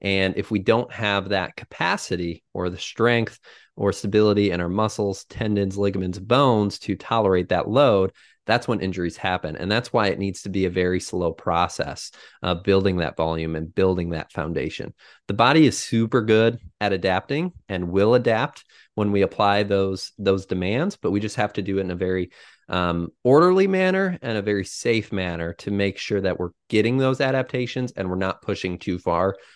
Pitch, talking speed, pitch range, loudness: 100 Hz, 190 wpm, 90-110 Hz, -22 LUFS